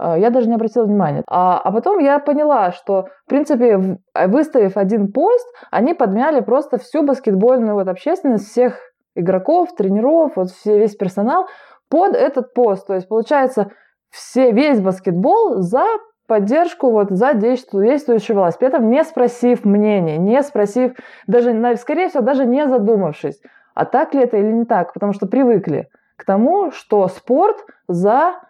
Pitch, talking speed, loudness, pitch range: 240 Hz, 155 wpm, -16 LUFS, 205-280 Hz